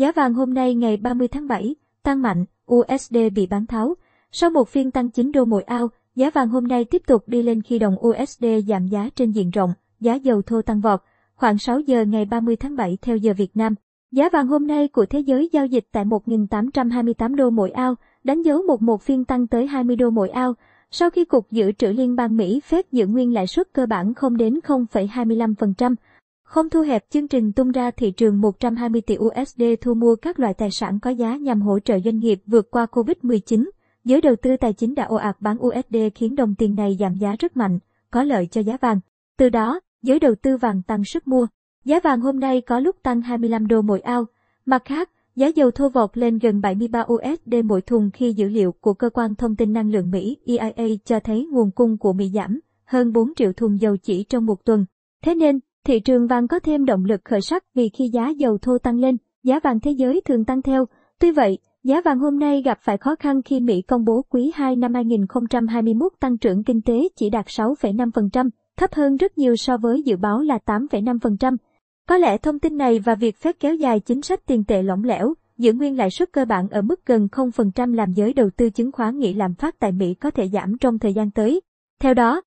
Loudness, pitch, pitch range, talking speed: -20 LUFS, 240 Hz, 220-265 Hz, 230 wpm